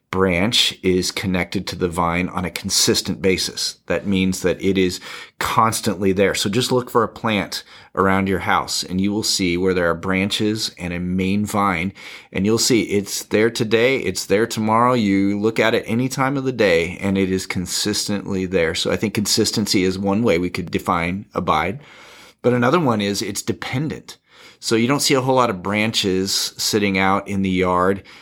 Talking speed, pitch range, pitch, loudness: 195 wpm, 95-110 Hz, 100 Hz, -19 LUFS